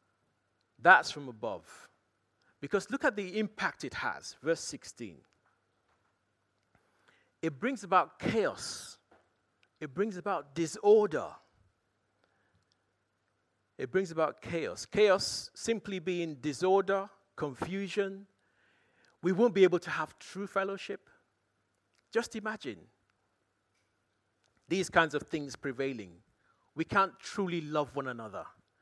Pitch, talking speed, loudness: 160 Hz, 105 wpm, -32 LUFS